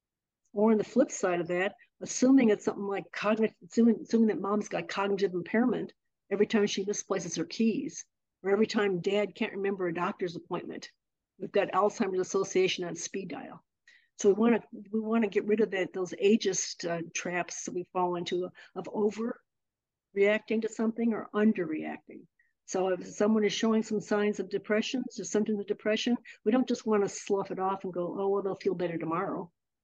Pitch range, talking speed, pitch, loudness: 185-220 Hz, 185 wpm, 205 Hz, -30 LUFS